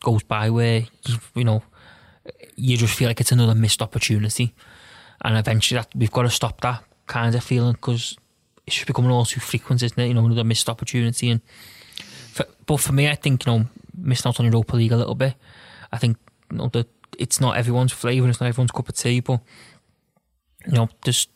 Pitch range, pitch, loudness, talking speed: 115-125 Hz, 120 Hz, -21 LUFS, 215 wpm